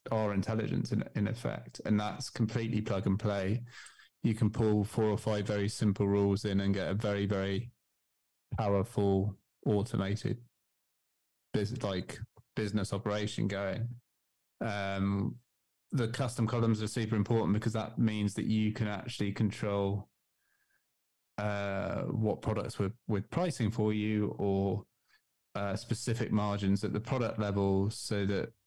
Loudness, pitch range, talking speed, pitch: -33 LUFS, 100-115 Hz, 140 wpm, 105 Hz